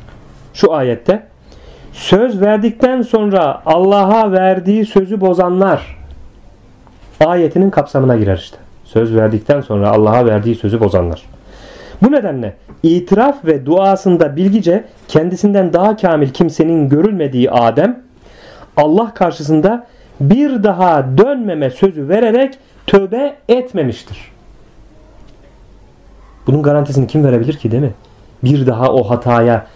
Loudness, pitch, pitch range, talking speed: -12 LUFS, 160 Hz, 120-200 Hz, 105 wpm